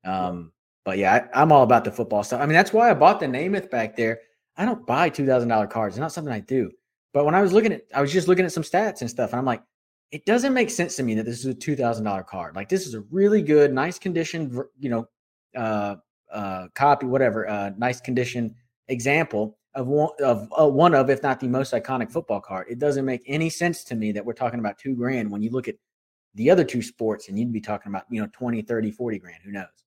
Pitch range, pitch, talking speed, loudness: 110-150 Hz, 125 Hz, 250 wpm, -23 LUFS